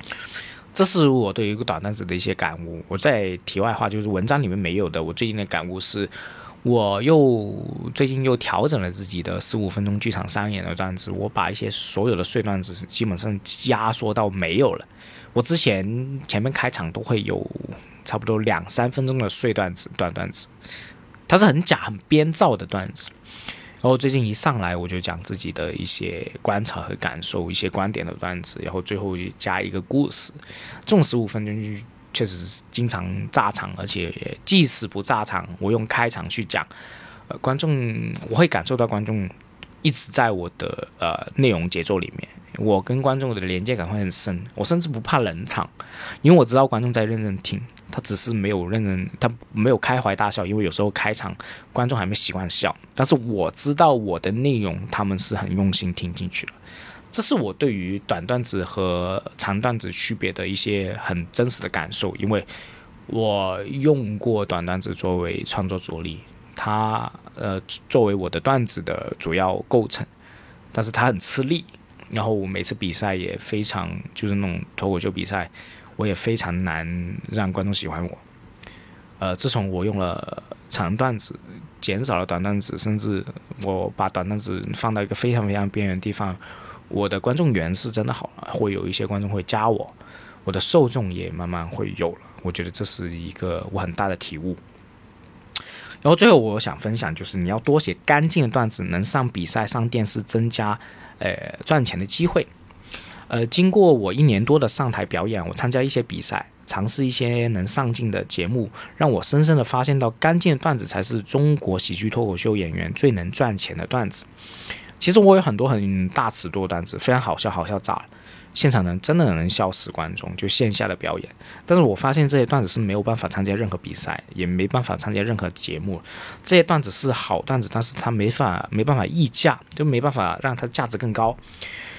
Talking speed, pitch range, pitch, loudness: 285 characters per minute, 95-125 Hz, 105 Hz, -21 LUFS